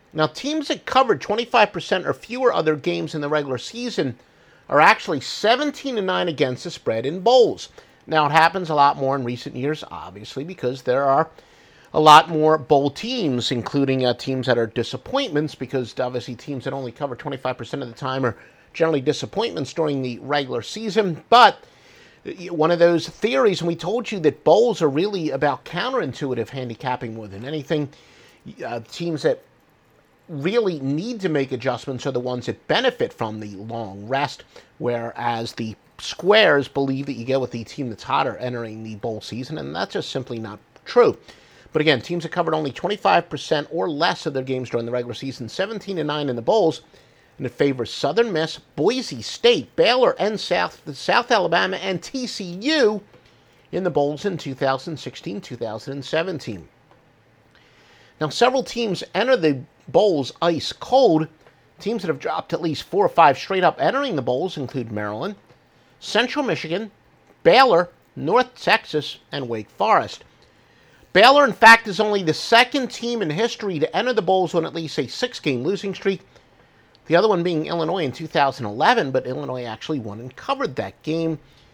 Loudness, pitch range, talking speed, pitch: -21 LUFS, 125-185 Hz, 170 wpm, 150 Hz